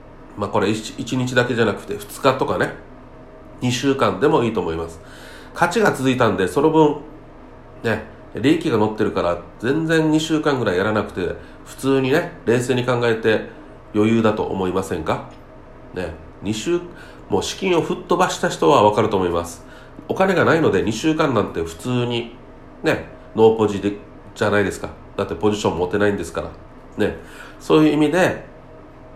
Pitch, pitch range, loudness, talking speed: 120 Hz, 100-150 Hz, -20 LUFS, 325 characters per minute